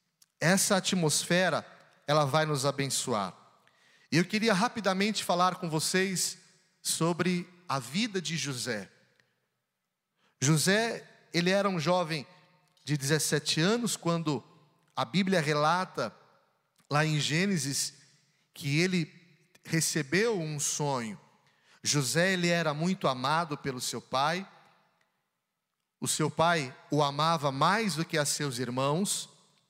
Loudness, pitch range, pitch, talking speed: -29 LUFS, 150-185 Hz, 165 Hz, 115 wpm